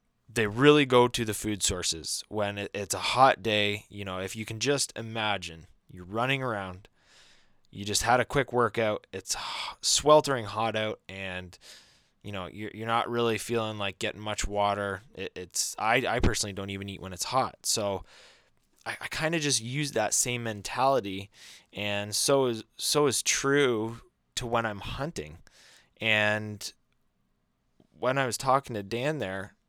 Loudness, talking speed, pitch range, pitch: -28 LUFS, 170 wpm, 100-120 Hz, 110 Hz